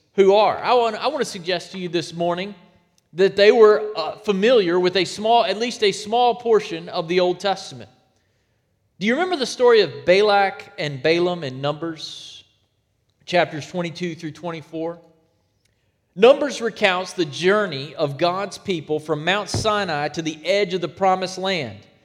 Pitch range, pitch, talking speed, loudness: 150-205 Hz, 180 Hz, 165 wpm, -20 LUFS